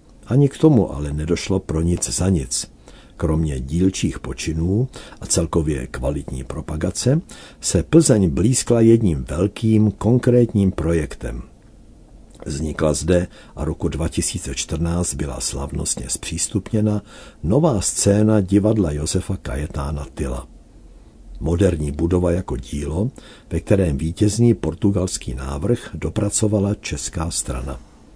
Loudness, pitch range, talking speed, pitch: -20 LUFS, 75-105 Hz, 105 wpm, 85 Hz